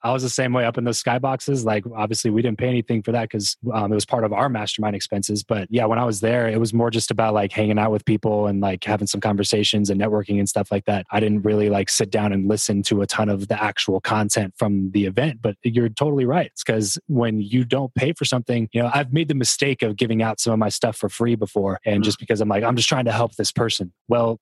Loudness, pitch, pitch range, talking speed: -21 LUFS, 110 Hz, 105-120 Hz, 275 wpm